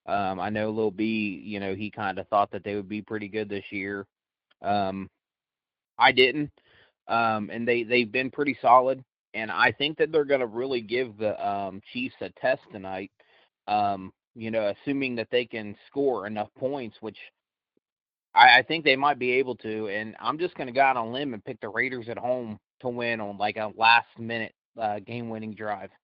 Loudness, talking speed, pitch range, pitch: -26 LUFS, 200 wpm, 105-125 Hz, 110 Hz